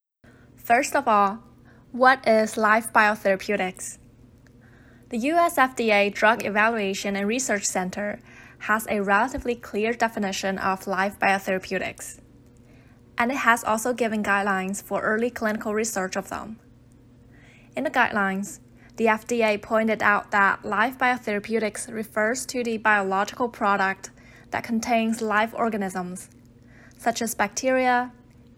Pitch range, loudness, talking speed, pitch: 185-230 Hz, -23 LUFS, 120 wpm, 205 Hz